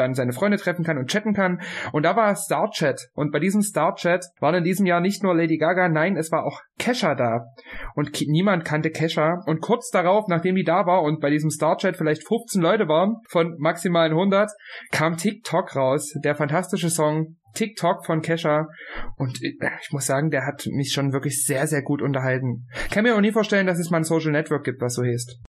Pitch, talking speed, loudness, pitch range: 160 Hz, 215 wpm, -22 LUFS, 145-185 Hz